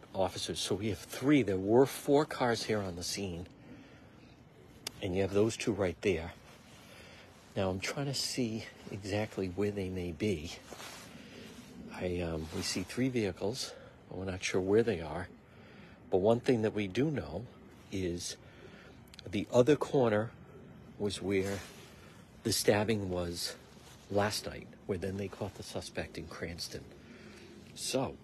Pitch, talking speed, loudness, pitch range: 100 Hz, 150 wpm, -34 LUFS, 95-115 Hz